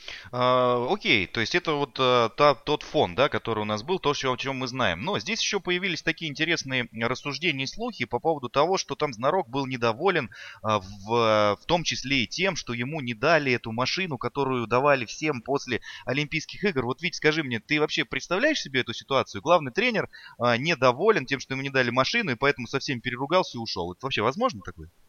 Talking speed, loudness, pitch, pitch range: 210 wpm, -25 LUFS, 135 Hz, 120-160 Hz